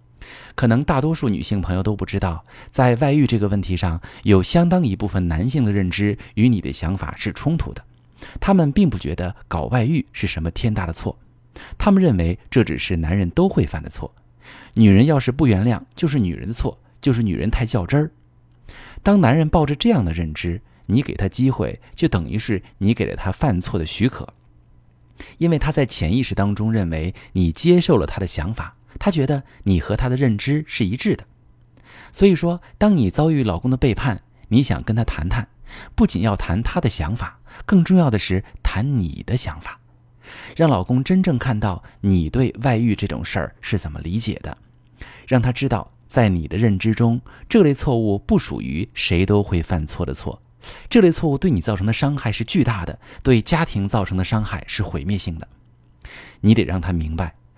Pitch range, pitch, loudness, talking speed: 95-130 Hz, 110 Hz, -20 LUFS, 280 characters per minute